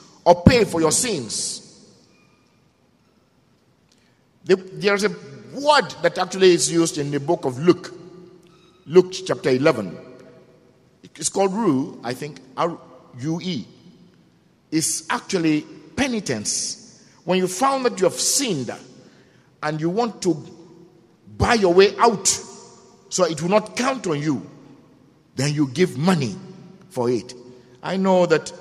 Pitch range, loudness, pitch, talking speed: 155-190 Hz, -20 LUFS, 175 Hz, 125 wpm